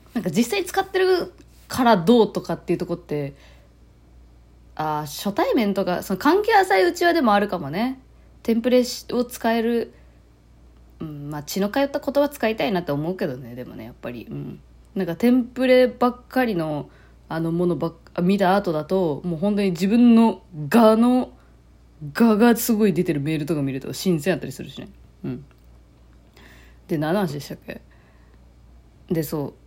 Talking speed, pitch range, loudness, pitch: 320 characters per minute, 140-230 Hz, -21 LUFS, 180 Hz